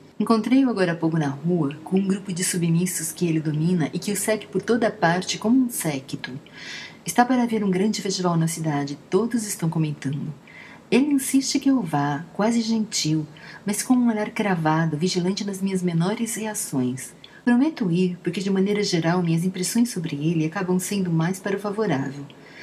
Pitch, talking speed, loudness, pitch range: 185 Hz, 180 wpm, -23 LUFS, 165-215 Hz